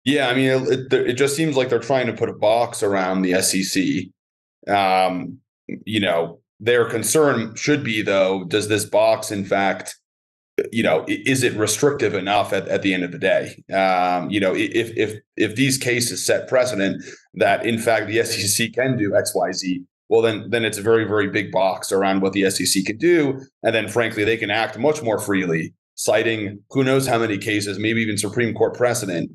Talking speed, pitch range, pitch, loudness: 195 wpm, 95-125 Hz, 110 Hz, -20 LUFS